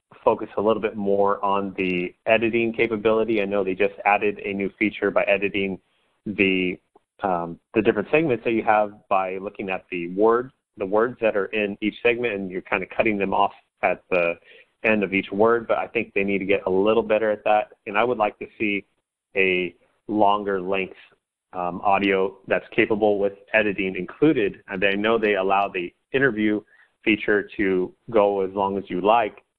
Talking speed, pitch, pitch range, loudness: 195 wpm, 100 Hz, 95-110 Hz, -23 LUFS